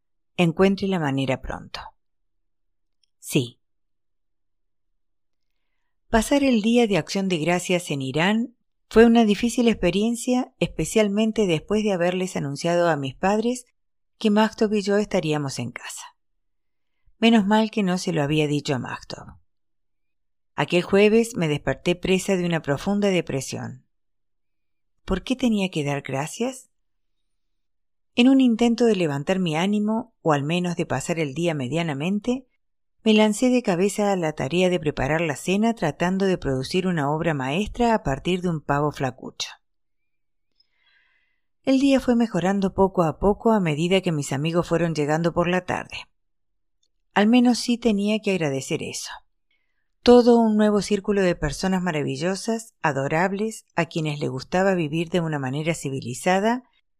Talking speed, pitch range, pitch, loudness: 145 wpm, 145-215 Hz, 175 Hz, -22 LUFS